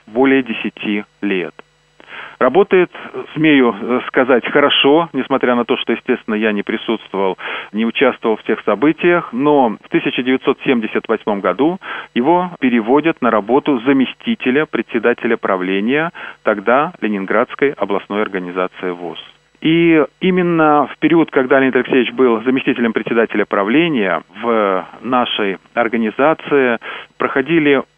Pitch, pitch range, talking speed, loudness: 130 Hz, 110-150 Hz, 110 wpm, -15 LUFS